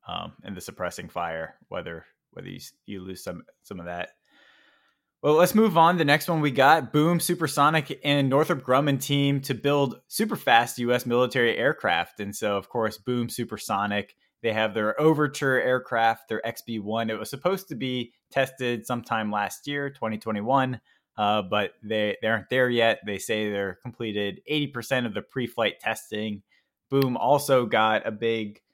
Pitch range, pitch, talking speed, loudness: 110-140 Hz, 120 Hz, 175 wpm, -25 LUFS